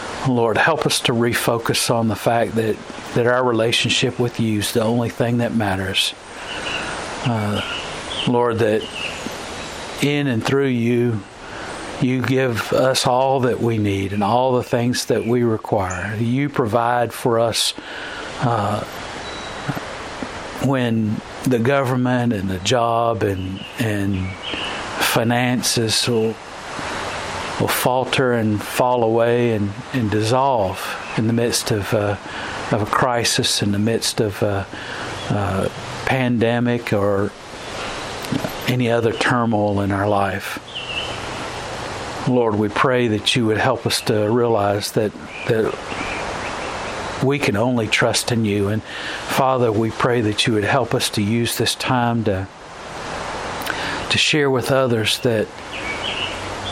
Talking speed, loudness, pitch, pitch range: 130 wpm, -20 LUFS, 115 Hz, 105-125 Hz